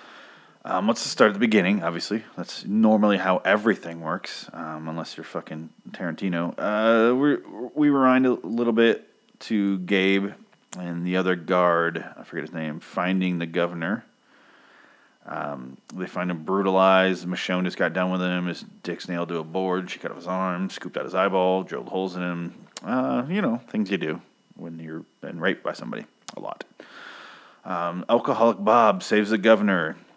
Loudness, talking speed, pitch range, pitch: -24 LUFS, 175 wpm, 85-100 Hz, 95 Hz